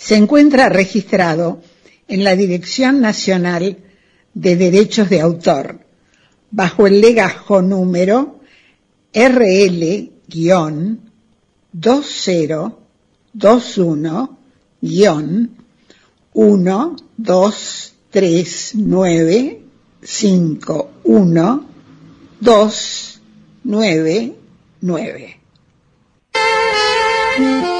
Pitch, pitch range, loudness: 205 Hz, 180-230 Hz, -14 LUFS